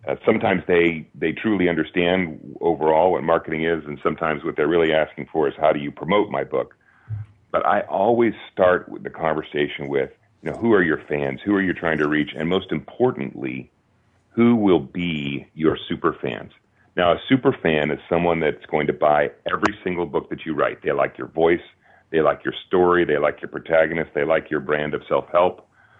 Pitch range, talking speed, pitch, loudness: 75-90 Hz, 205 wpm, 85 Hz, -21 LUFS